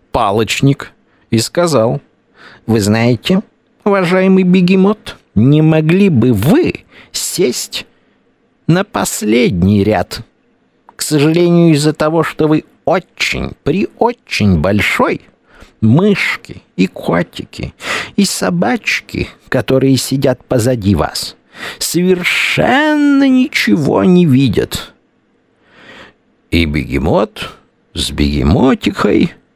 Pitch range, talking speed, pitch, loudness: 115-185 Hz, 85 wpm, 150 Hz, -13 LUFS